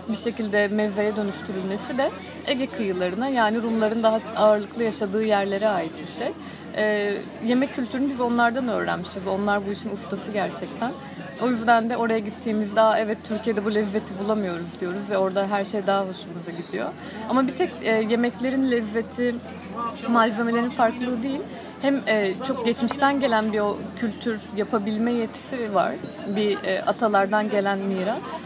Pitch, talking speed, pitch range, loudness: 220 Hz, 140 wpm, 205-235 Hz, -24 LUFS